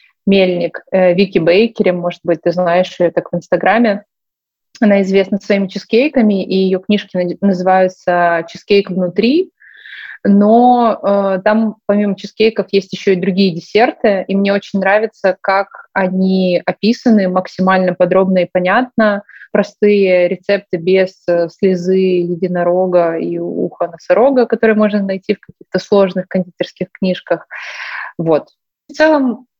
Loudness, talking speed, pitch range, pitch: -14 LUFS, 125 wpm, 180-210 Hz, 190 Hz